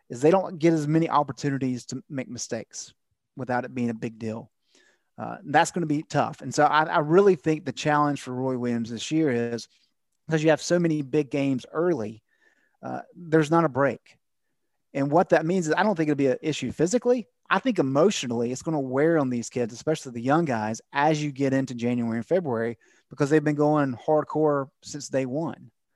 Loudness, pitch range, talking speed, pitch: -25 LUFS, 125-160 Hz, 210 wpm, 145 Hz